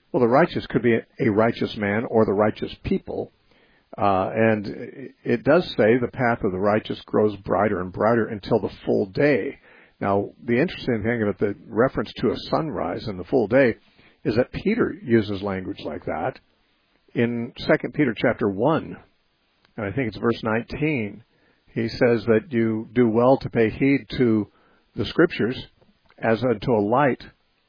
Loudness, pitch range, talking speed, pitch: -23 LUFS, 105-120 Hz, 170 wpm, 115 Hz